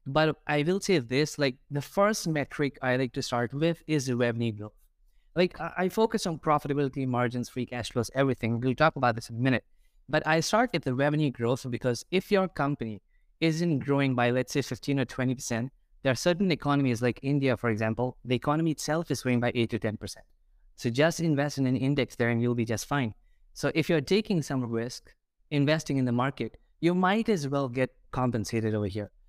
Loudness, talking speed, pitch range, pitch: -28 LUFS, 205 wpm, 120-155 Hz, 135 Hz